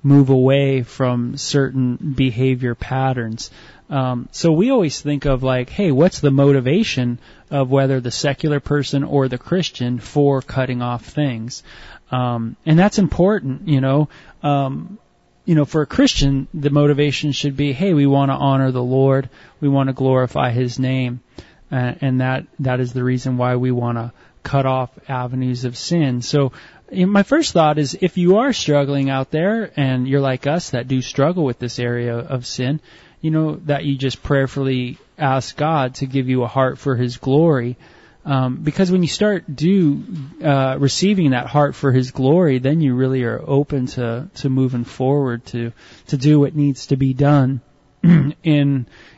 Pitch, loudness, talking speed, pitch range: 135 Hz, -18 LUFS, 175 wpm, 125-145 Hz